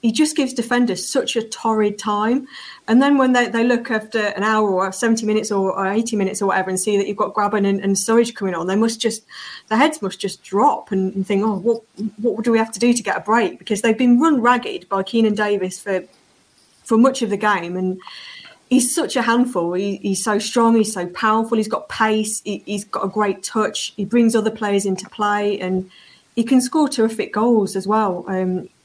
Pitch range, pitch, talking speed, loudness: 195-230 Hz, 215 Hz, 230 wpm, -19 LUFS